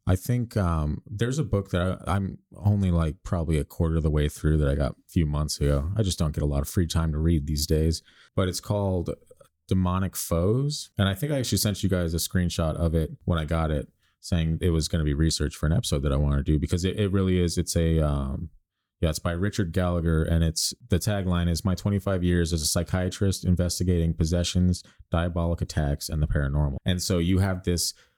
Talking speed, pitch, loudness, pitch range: 235 wpm, 85 Hz, -26 LUFS, 80-95 Hz